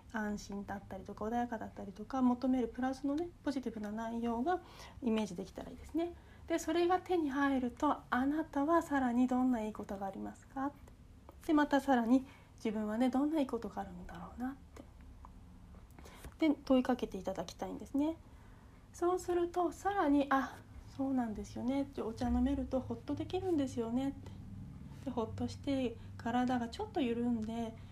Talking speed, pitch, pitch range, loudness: 370 characters per minute, 260 Hz, 230-290 Hz, -36 LUFS